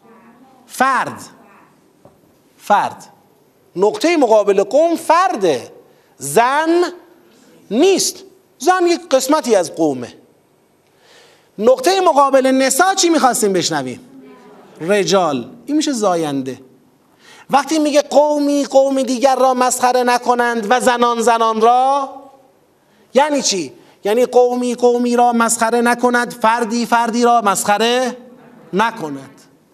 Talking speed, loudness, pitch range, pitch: 95 wpm, -15 LUFS, 225-290 Hz, 250 Hz